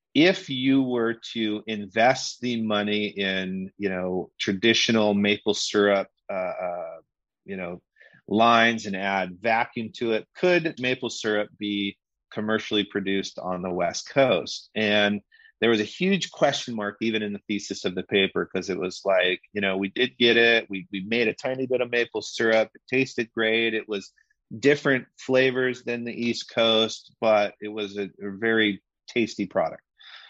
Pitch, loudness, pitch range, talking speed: 110 Hz, -24 LUFS, 100-120 Hz, 170 wpm